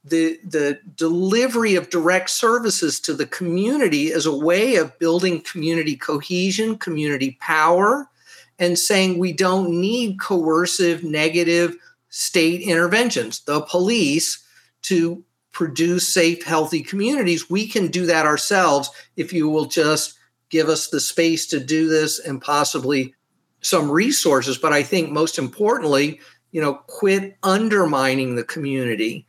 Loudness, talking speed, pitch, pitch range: -19 LUFS, 135 wpm, 170 Hz, 155-185 Hz